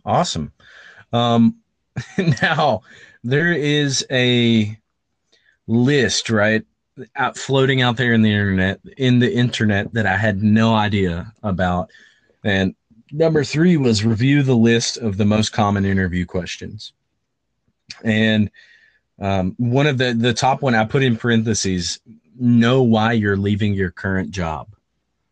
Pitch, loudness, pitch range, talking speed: 115 Hz, -18 LUFS, 100-125 Hz, 135 wpm